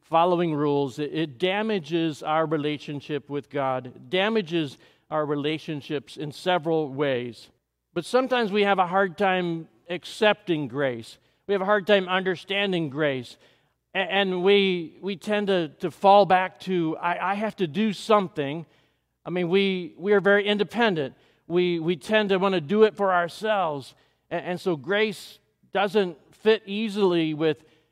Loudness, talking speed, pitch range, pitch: -25 LUFS, 145 wpm, 155-200 Hz, 180 Hz